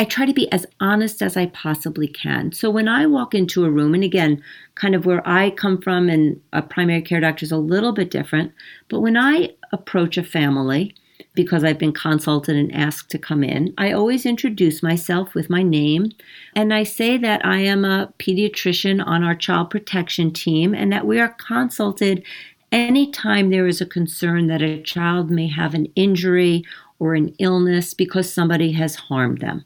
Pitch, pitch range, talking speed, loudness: 180 Hz, 160-200 Hz, 190 wpm, -19 LUFS